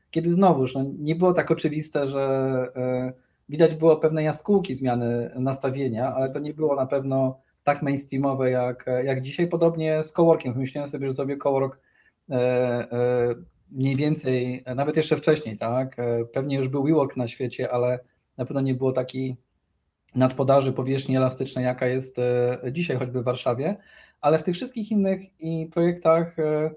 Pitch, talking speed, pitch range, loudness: 135 Hz, 145 wpm, 125-155 Hz, -24 LUFS